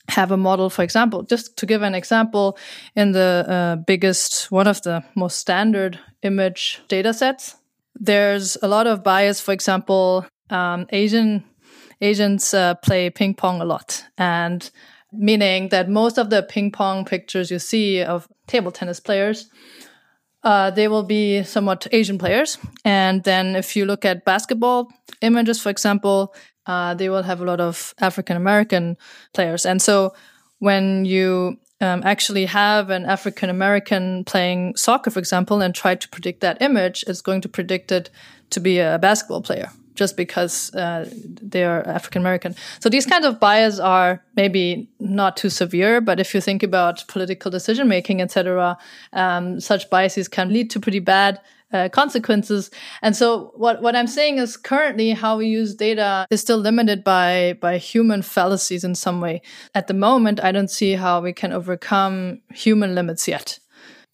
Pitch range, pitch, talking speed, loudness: 185-215 Hz, 195 Hz, 170 wpm, -19 LUFS